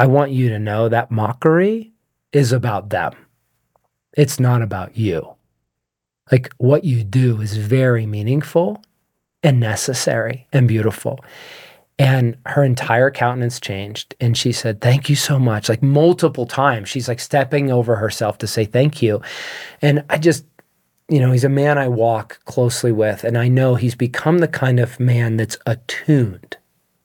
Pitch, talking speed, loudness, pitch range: 125 Hz, 160 wpm, -17 LUFS, 115-140 Hz